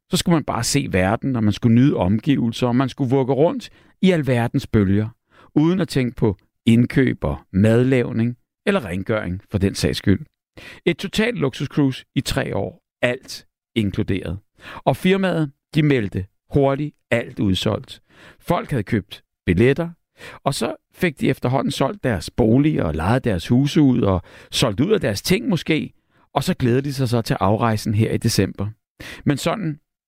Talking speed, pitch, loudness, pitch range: 170 wpm, 120 Hz, -20 LUFS, 105-145 Hz